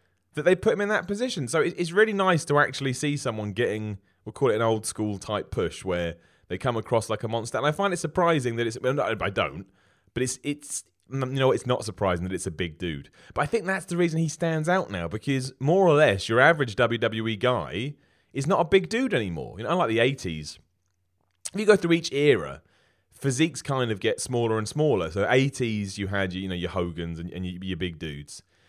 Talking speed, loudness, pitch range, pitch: 230 wpm, -26 LUFS, 95-150 Hz, 120 Hz